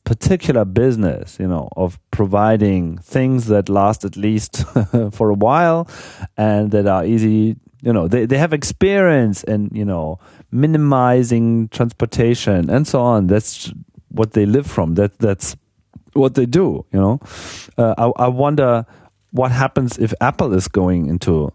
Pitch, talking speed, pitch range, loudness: 110 Hz, 155 wpm, 100-125 Hz, -16 LUFS